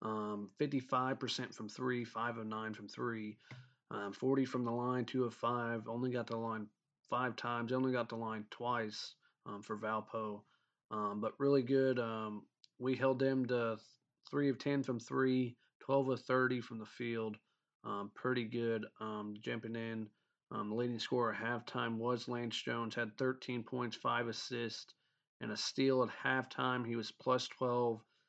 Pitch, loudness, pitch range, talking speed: 120 Hz, -38 LUFS, 110-130 Hz, 170 wpm